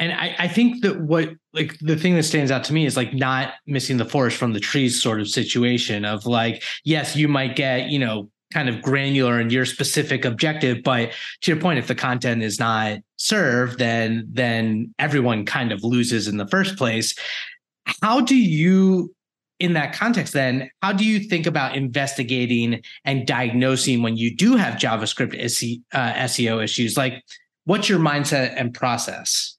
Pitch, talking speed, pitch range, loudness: 130 Hz, 185 wpm, 120-155 Hz, -21 LUFS